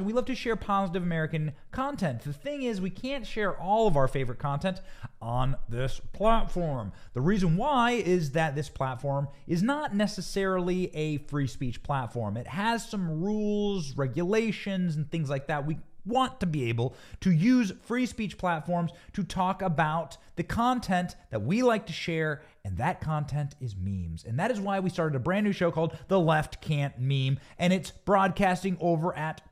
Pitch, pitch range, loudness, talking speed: 170 Hz, 140-200 Hz, -29 LUFS, 180 wpm